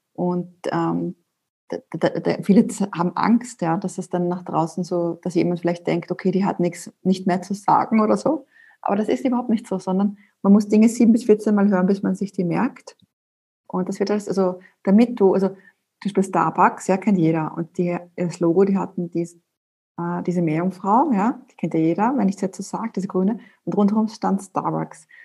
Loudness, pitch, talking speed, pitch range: -21 LUFS, 190 Hz, 215 wpm, 175-210 Hz